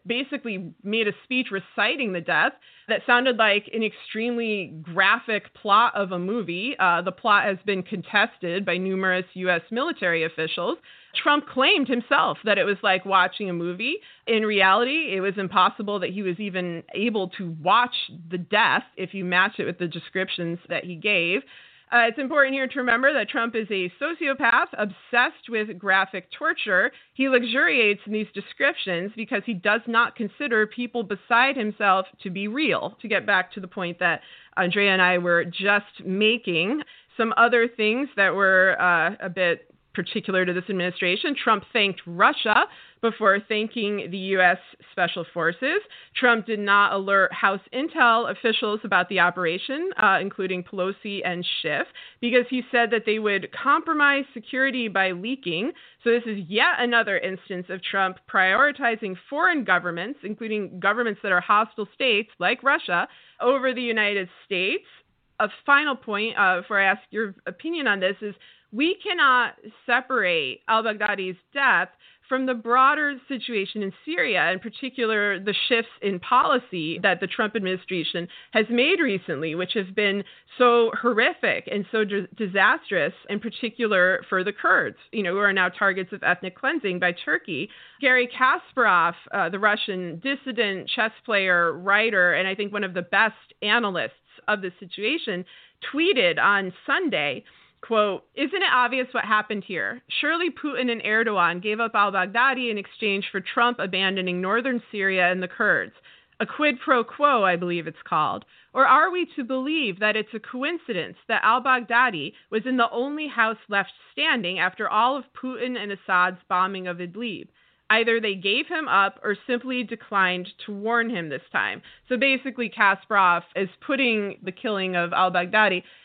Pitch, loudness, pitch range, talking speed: 210 Hz, -23 LUFS, 190-245 Hz, 165 wpm